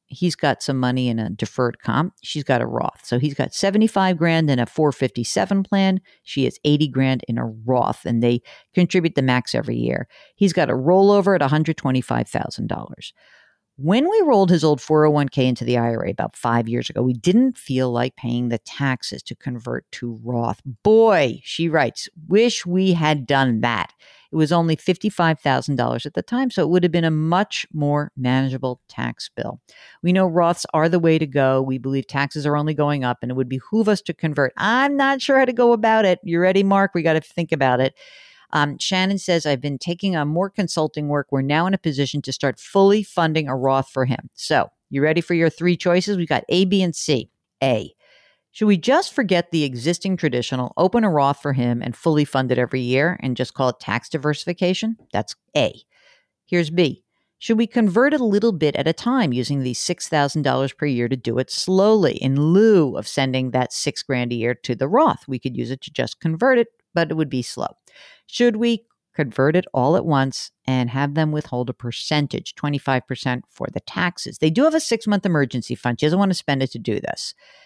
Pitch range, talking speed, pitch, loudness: 130-185 Hz, 210 wpm, 150 Hz, -20 LUFS